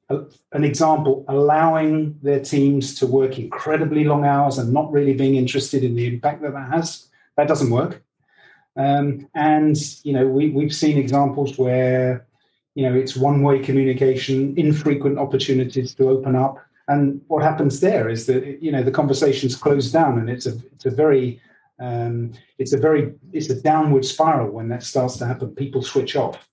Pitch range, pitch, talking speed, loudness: 130-150 Hz, 140 Hz, 175 wpm, -19 LUFS